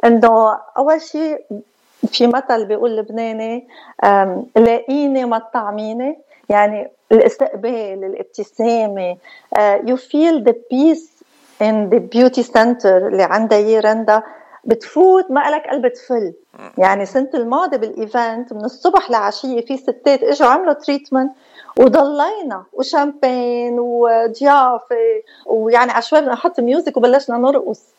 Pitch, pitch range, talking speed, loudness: 245 Hz, 225-285 Hz, 110 wpm, -15 LUFS